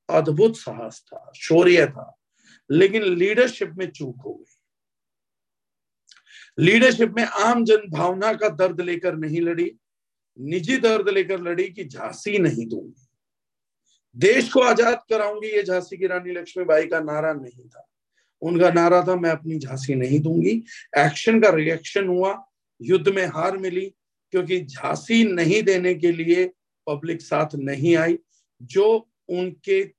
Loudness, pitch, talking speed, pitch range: -21 LUFS, 180 Hz, 140 wpm, 160-210 Hz